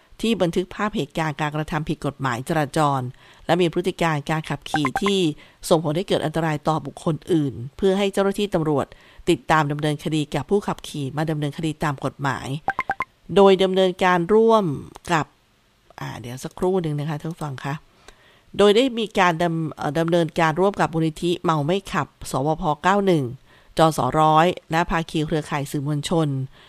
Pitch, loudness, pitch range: 160 Hz, -22 LUFS, 150-180 Hz